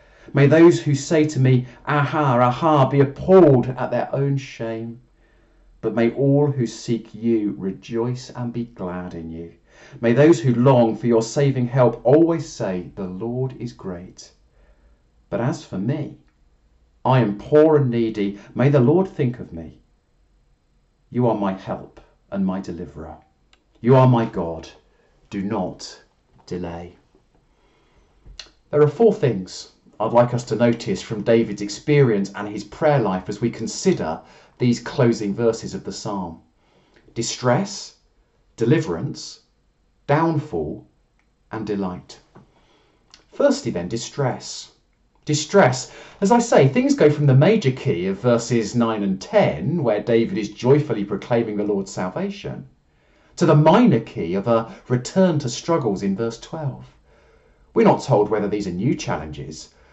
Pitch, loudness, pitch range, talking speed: 120 Hz, -20 LUFS, 100-145 Hz, 145 wpm